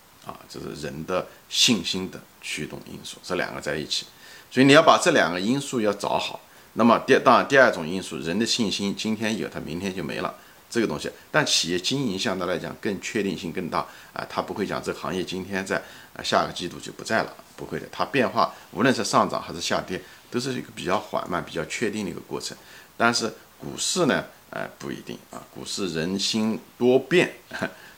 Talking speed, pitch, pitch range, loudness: 315 characters per minute, 100 Hz, 90-115 Hz, -24 LUFS